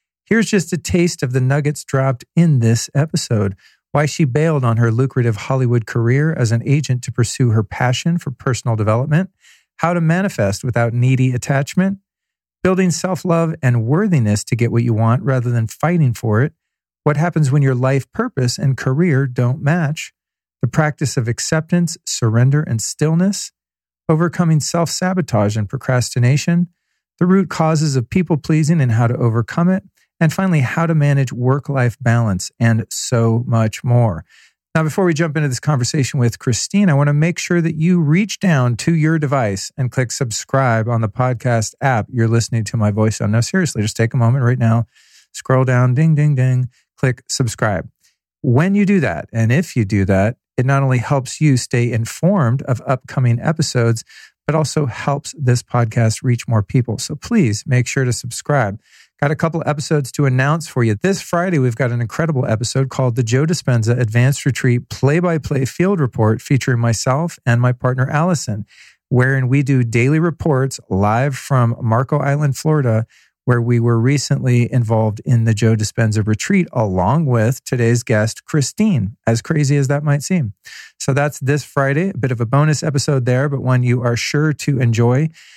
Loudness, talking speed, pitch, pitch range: -17 LUFS, 180 wpm, 130 Hz, 120-155 Hz